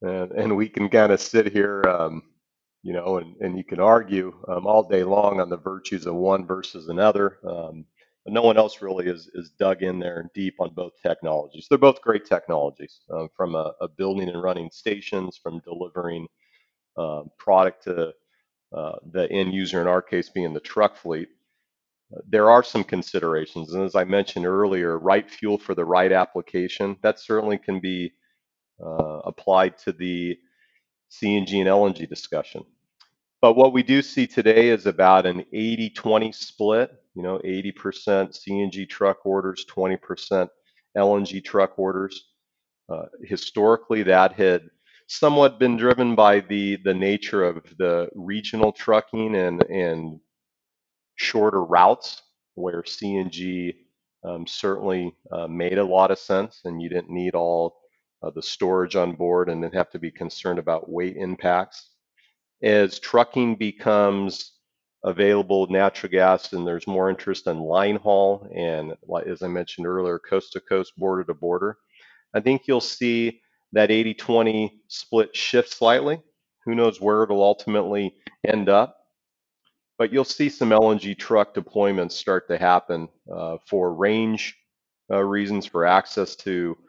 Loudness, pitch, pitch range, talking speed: -22 LUFS, 95 Hz, 90-105 Hz, 155 wpm